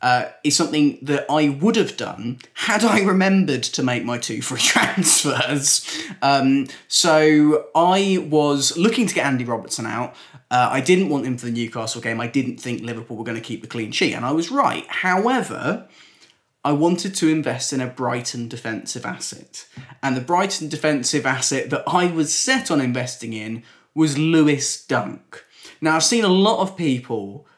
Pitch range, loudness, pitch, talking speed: 125-170 Hz, -19 LUFS, 145 Hz, 180 wpm